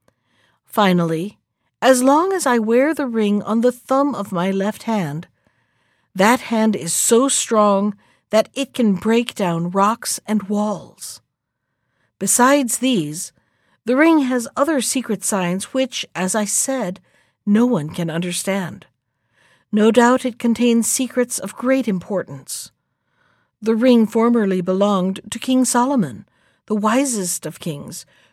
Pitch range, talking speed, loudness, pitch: 195-250 Hz, 135 wpm, -18 LUFS, 220 Hz